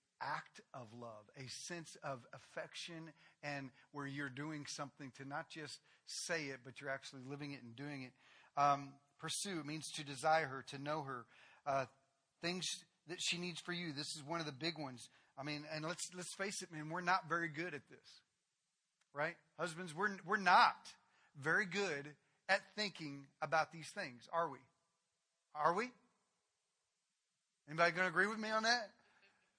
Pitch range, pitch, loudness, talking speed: 140-175 Hz, 155 Hz, -41 LUFS, 175 wpm